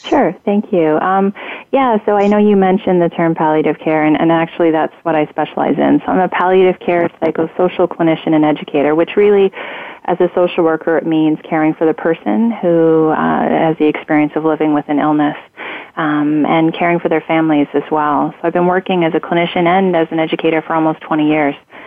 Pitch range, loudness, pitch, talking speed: 155-180 Hz, -14 LUFS, 165 Hz, 210 wpm